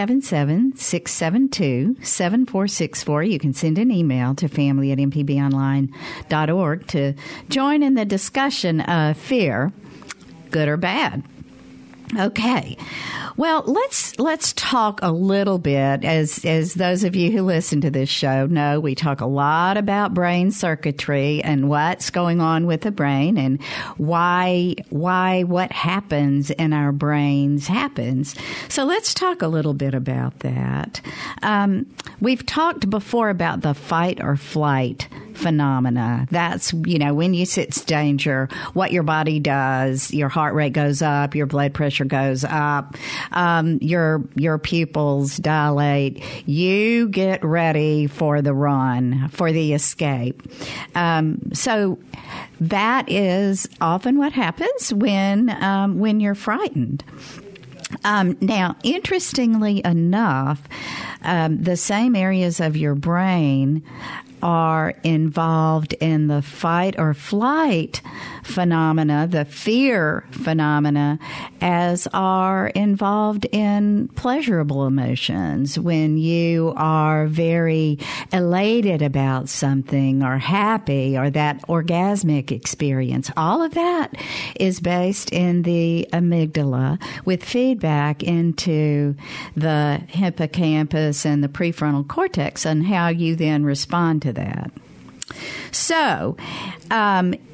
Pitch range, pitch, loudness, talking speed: 145-190 Hz, 160 Hz, -20 LUFS, 120 wpm